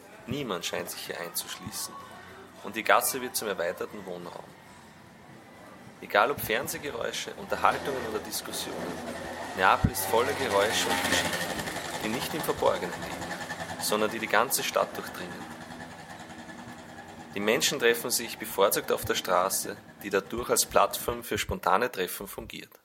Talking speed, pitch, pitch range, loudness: 135 wpm, 85 Hz, 80-90 Hz, -28 LUFS